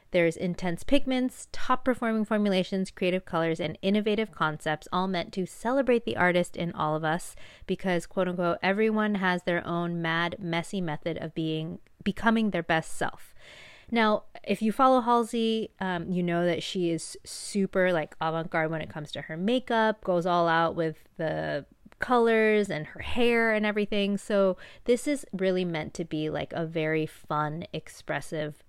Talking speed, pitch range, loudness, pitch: 165 wpm, 165-215 Hz, -28 LUFS, 180 Hz